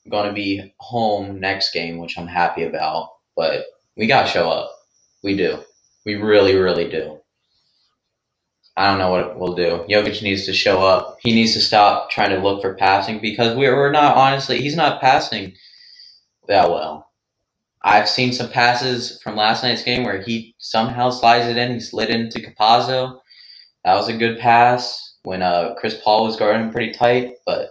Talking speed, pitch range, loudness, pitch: 180 wpm, 100-120 Hz, -18 LUFS, 110 Hz